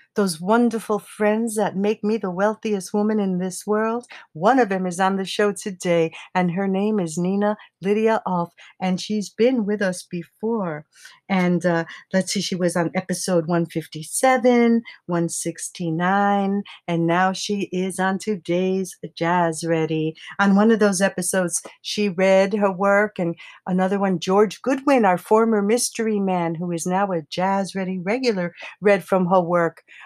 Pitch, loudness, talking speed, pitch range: 190 Hz, -21 LUFS, 160 wpm, 175-210 Hz